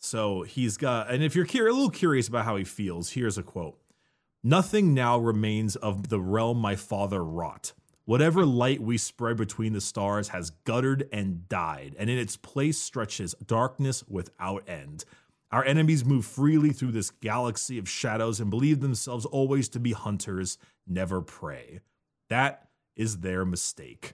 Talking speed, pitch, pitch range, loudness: 165 wpm, 115 Hz, 100-130 Hz, -28 LUFS